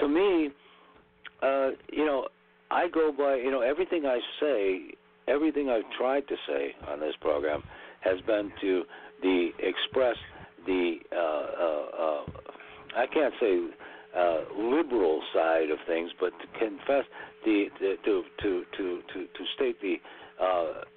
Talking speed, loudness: 145 wpm, -29 LUFS